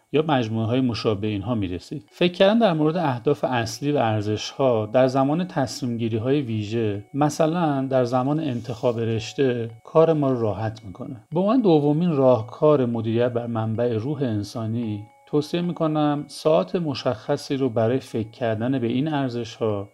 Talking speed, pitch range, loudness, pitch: 145 wpm, 115-150 Hz, -23 LUFS, 130 Hz